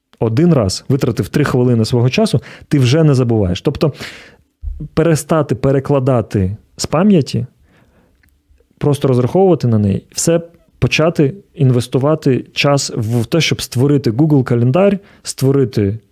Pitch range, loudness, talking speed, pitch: 120-155 Hz, -14 LUFS, 115 wpm, 135 Hz